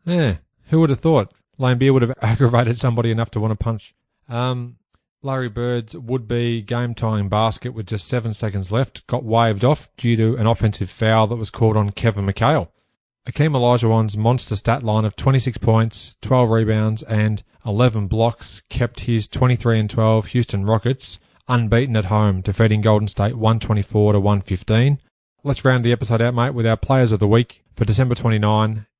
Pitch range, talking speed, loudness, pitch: 110-125 Hz, 180 wpm, -19 LUFS, 115 Hz